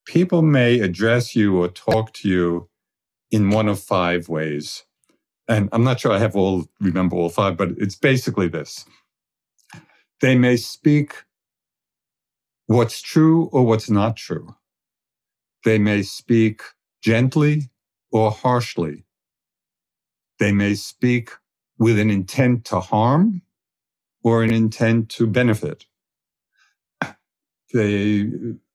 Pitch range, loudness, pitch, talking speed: 100-125 Hz, -19 LUFS, 110 Hz, 115 wpm